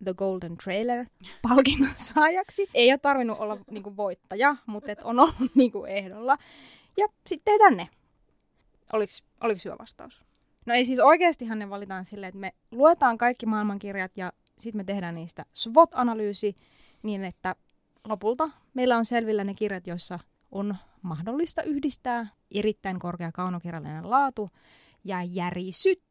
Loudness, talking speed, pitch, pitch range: -25 LUFS, 140 wpm, 215 Hz, 190-265 Hz